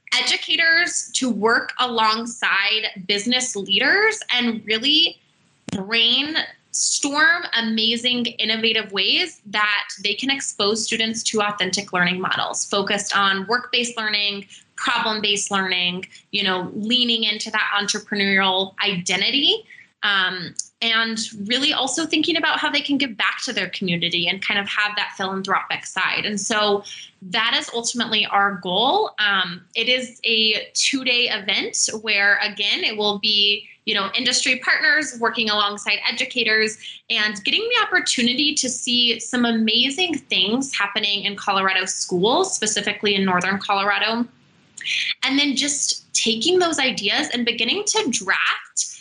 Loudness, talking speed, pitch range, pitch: -19 LUFS, 130 wpm, 205-255 Hz, 220 Hz